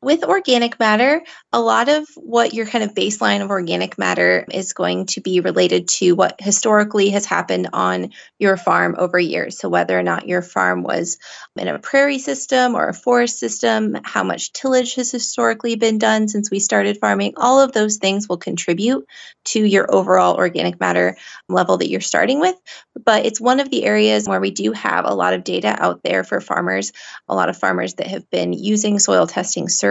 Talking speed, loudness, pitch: 200 wpm, -17 LUFS, 195 Hz